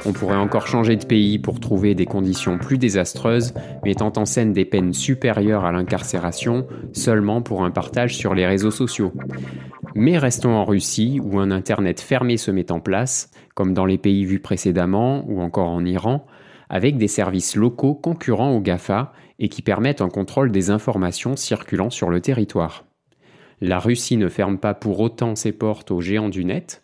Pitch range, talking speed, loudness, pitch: 95-120 Hz, 180 wpm, -20 LUFS, 105 Hz